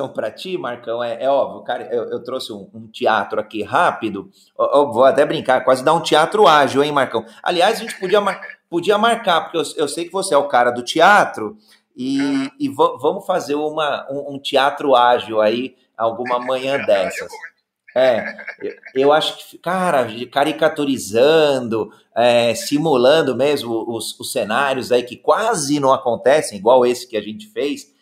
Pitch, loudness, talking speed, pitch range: 140 Hz, -17 LUFS, 180 wpm, 120-180 Hz